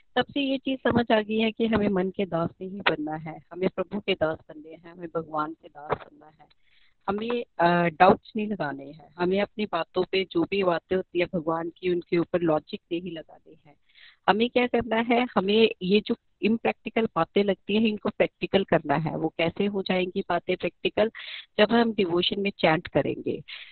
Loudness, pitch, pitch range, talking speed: -26 LUFS, 185 Hz, 165-210 Hz, 195 wpm